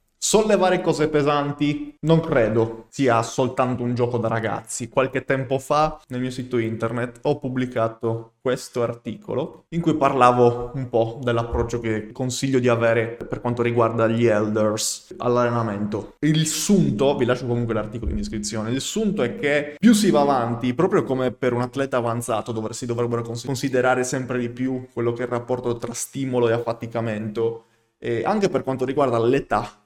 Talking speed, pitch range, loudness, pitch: 165 wpm, 115-135 Hz, -22 LUFS, 120 Hz